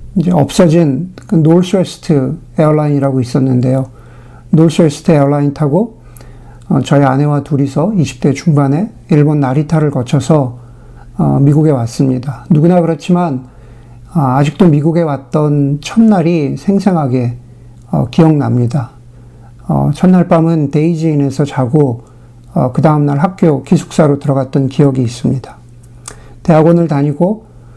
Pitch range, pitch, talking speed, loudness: 130-165 Hz, 145 Hz, 275 characters per minute, -12 LUFS